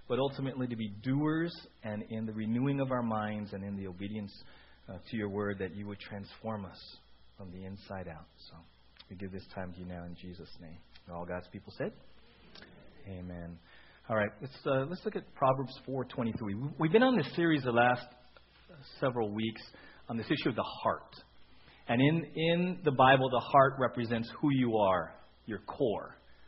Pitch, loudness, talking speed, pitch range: 110 Hz, -33 LUFS, 185 wpm, 95-135 Hz